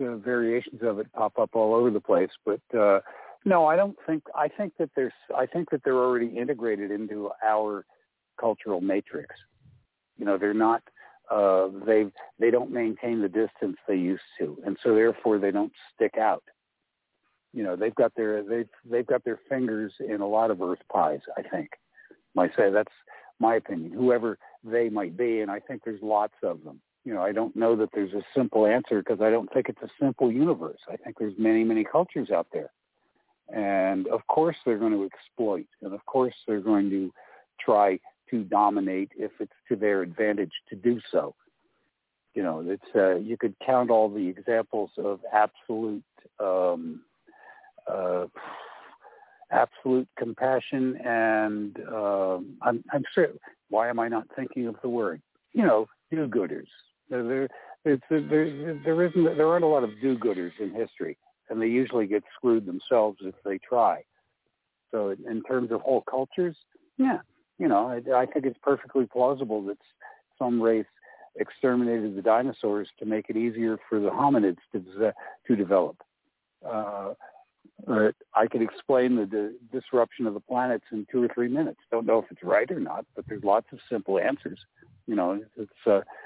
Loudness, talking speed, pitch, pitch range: -27 LUFS, 175 wpm, 115 Hz, 105-130 Hz